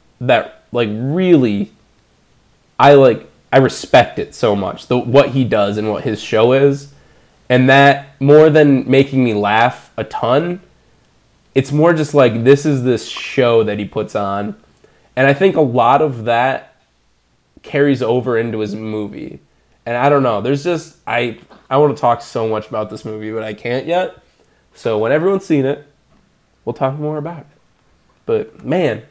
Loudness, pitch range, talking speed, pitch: -15 LUFS, 110-145 Hz, 175 wpm, 130 Hz